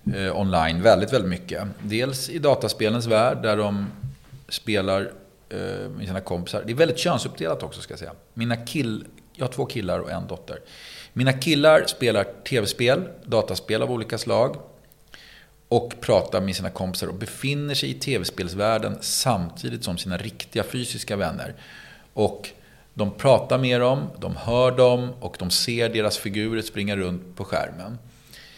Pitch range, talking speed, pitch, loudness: 100-125 Hz, 150 wpm, 110 Hz, -24 LUFS